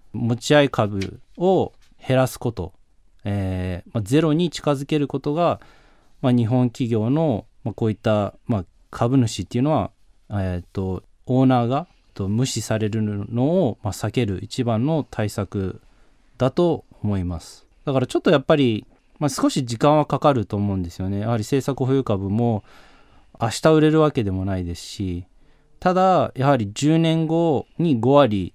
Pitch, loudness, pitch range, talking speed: 120 Hz, -21 LUFS, 100-145 Hz, 300 characters per minute